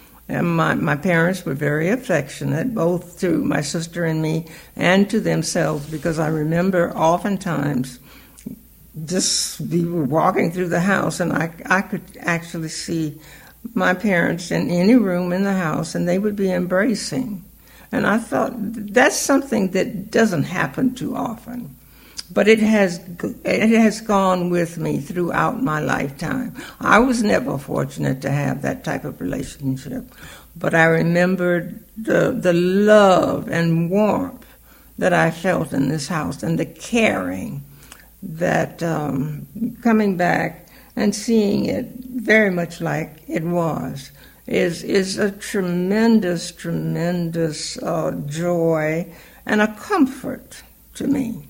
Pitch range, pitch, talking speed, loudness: 165-215 Hz, 180 Hz, 135 wpm, -20 LUFS